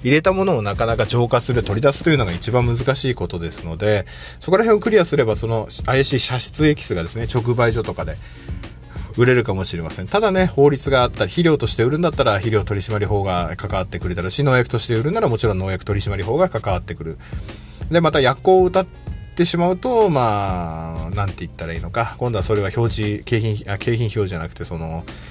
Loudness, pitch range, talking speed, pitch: -18 LUFS, 95-135 Hz, 450 characters per minute, 110 Hz